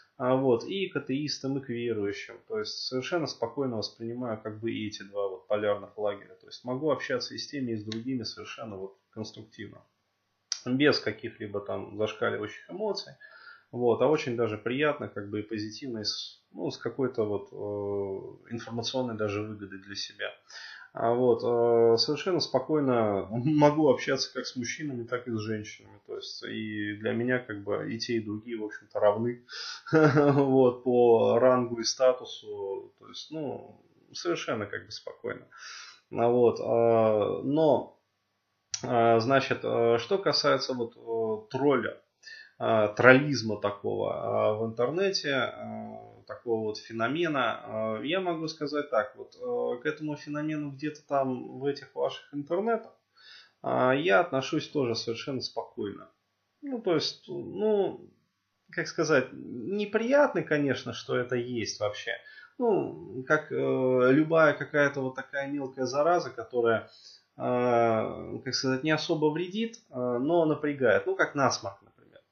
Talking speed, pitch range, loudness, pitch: 130 wpm, 110-150 Hz, -29 LUFS, 125 Hz